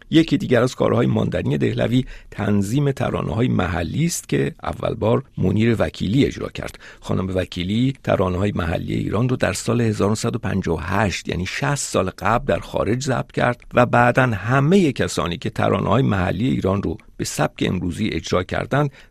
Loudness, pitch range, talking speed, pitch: -20 LUFS, 95-130 Hz, 160 wpm, 110 Hz